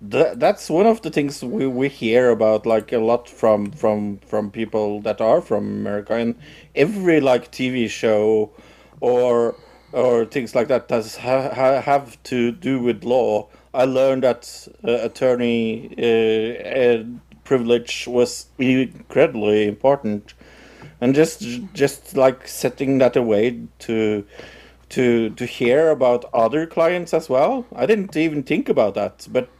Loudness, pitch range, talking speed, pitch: -19 LUFS, 115-135 Hz, 150 wpm, 125 Hz